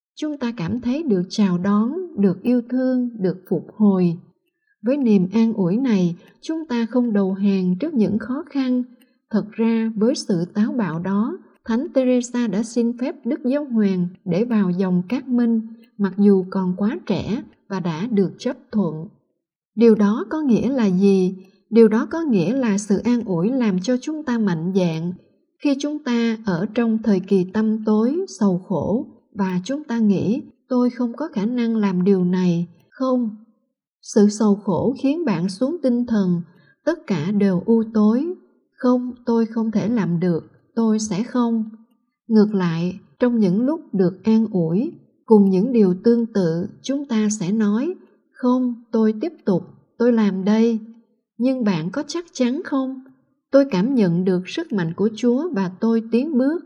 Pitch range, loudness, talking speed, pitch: 195-250 Hz, -20 LUFS, 175 wpm, 225 Hz